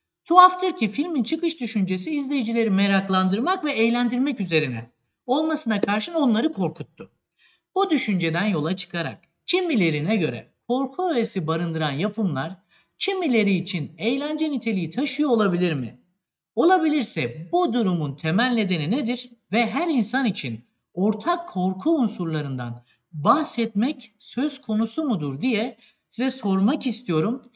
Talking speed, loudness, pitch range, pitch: 115 wpm, -23 LUFS, 180-270 Hz, 225 Hz